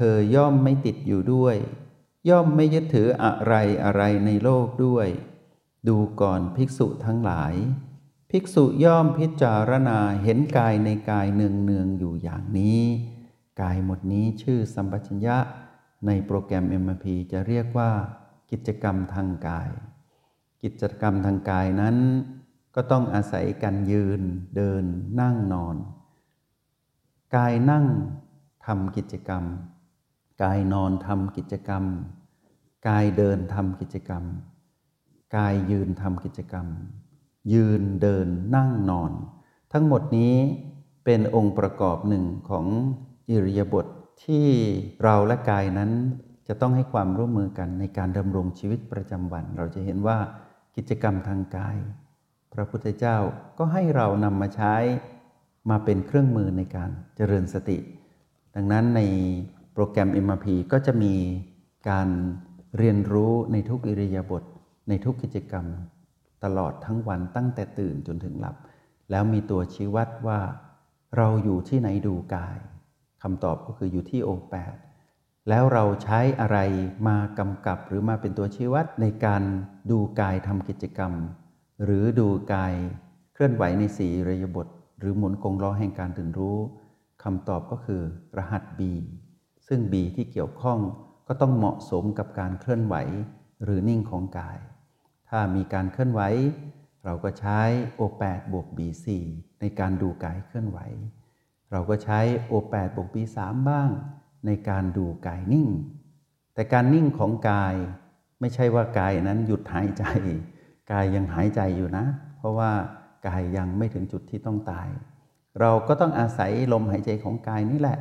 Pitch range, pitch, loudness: 95-125 Hz, 105 Hz, -25 LUFS